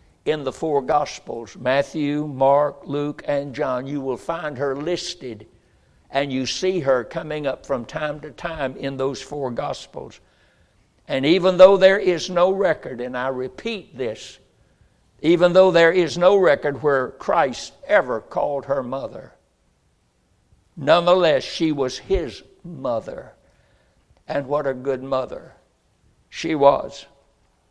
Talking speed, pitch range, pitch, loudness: 135 wpm, 135-170 Hz, 145 Hz, -21 LUFS